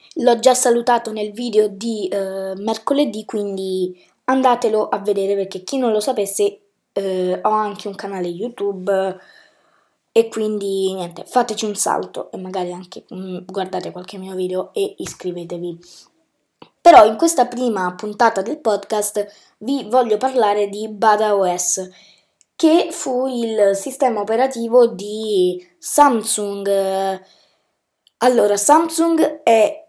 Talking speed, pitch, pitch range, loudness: 125 wpm, 215 Hz, 195-250 Hz, -18 LUFS